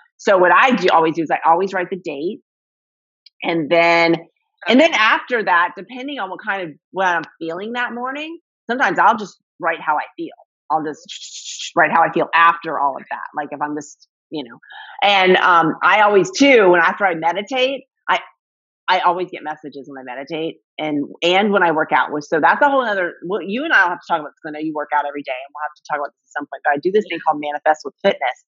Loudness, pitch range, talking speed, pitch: -17 LUFS, 150-220 Hz, 240 wpm, 170 Hz